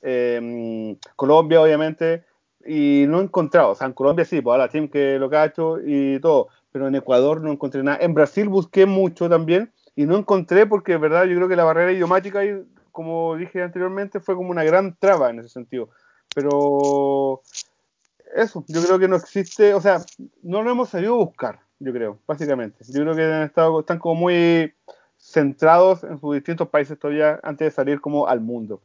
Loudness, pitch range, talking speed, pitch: -19 LUFS, 145-185 Hz, 200 wpm, 165 Hz